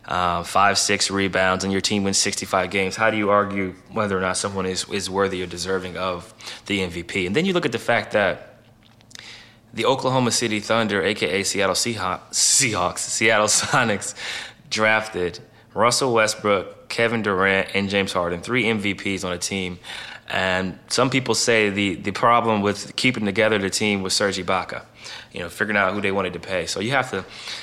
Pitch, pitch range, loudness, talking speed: 100 Hz, 95-110 Hz, -21 LUFS, 185 wpm